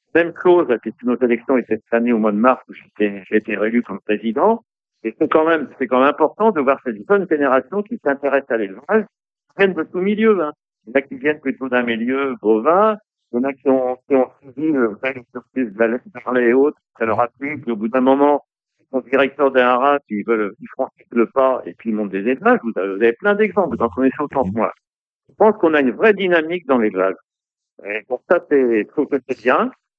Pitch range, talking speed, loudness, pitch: 115-155 Hz, 250 wpm, -18 LUFS, 130 Hz